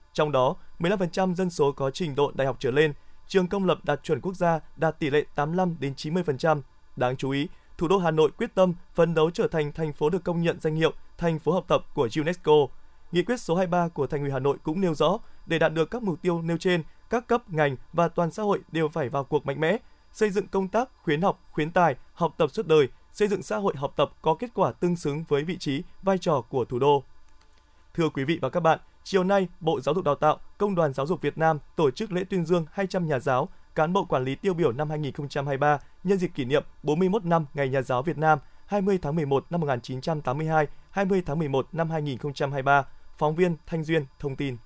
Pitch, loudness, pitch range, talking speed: 160 Hz, -26 LUFS, 145-185 Hz, 240 wpm